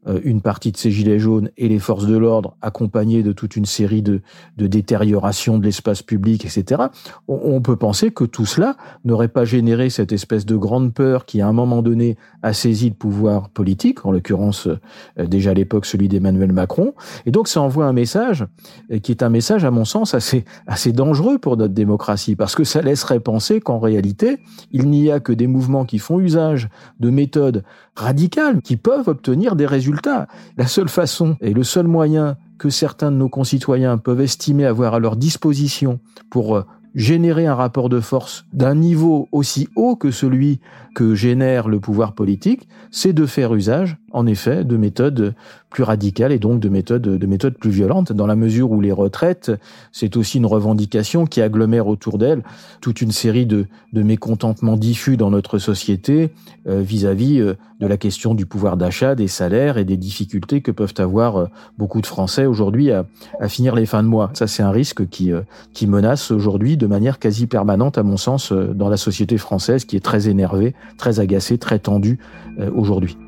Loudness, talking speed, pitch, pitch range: -17 LUFS, 190 wpm, 115 Hz, 105-135 Hz